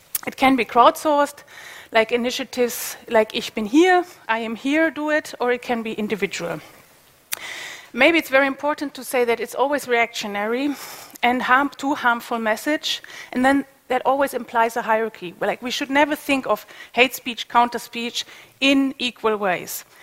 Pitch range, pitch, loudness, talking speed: 230-285 Hz, 250 Hz, -21 LUFS, 165 wpm